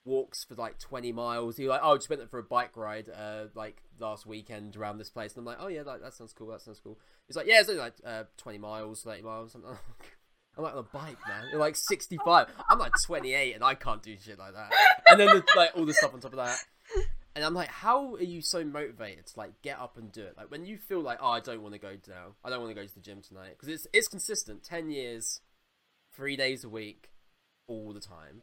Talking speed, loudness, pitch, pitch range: 265 wpm, -26 LUFS, 115 Hz, 110-165 Hz